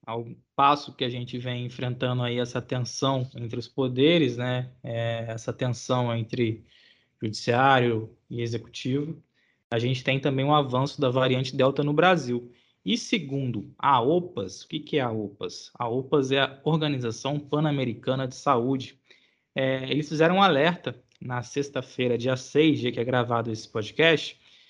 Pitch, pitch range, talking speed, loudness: 130 Hz, 120-140 Hz, 160 wpm, -26 LUFS